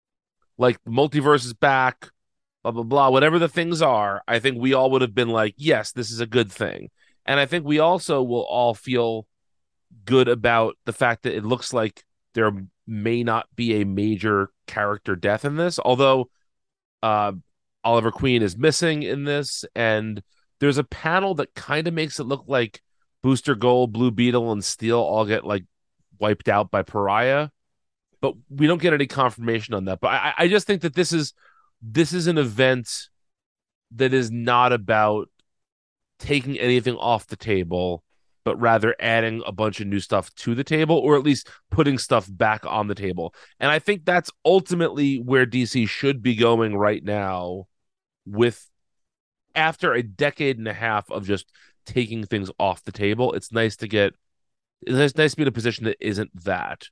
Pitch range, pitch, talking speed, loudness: 110-140 Hz, 120 Hz, 180 wpm, -22 LUFS